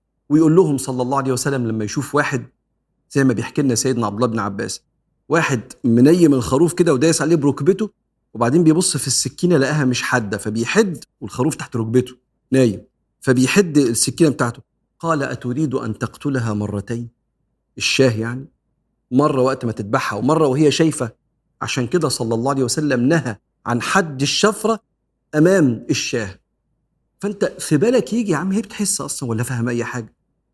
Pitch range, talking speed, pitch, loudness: 120-160 Hz, 155 wpm, 135 Hz, -18 LUFS